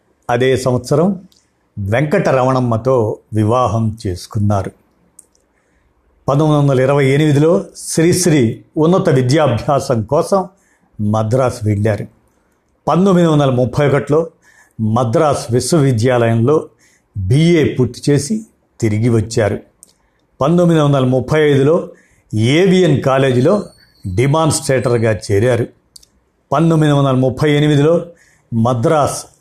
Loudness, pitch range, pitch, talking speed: -14 LUFS, 115-155 Hz, 130 Hz, 80 wpm